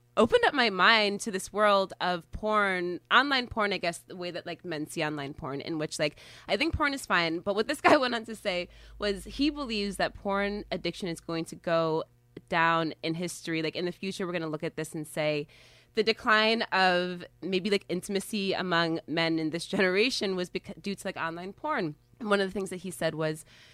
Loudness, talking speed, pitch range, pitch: -29 LUFS, 220 wpm, 165-205 Hz, 180 Hz